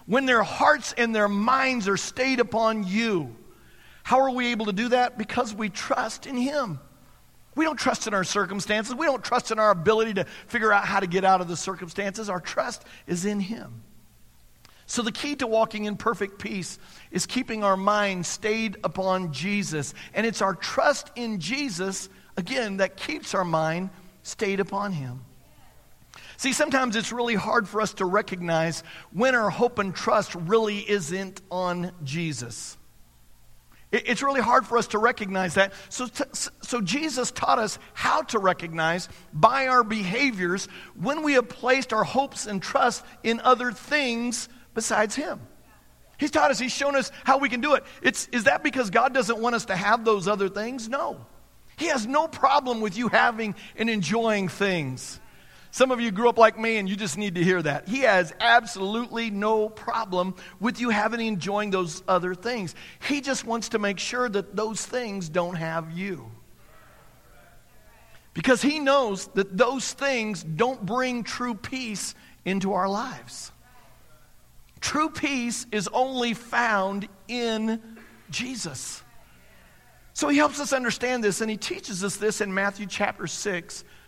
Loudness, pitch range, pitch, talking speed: -25 LUFS, 190-245 Hz, 215 Hz, 170 wpm